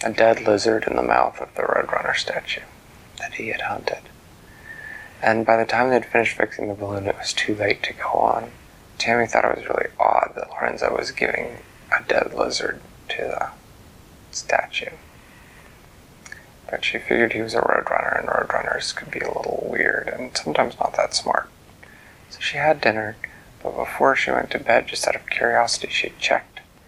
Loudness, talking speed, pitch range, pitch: -22 LUFS, 180 wpm, 105-115 Hz, 110 Hz